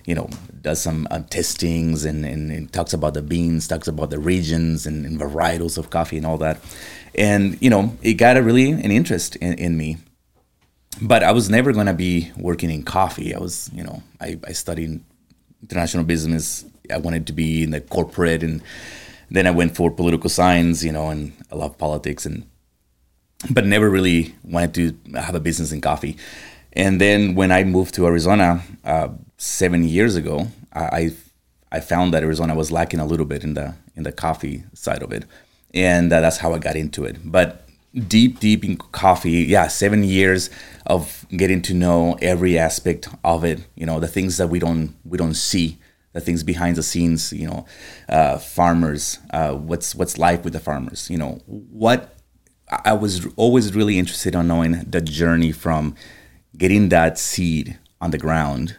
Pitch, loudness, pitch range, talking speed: 85 Hz, -19 LUFS, 80-90 Hz, 190 wpm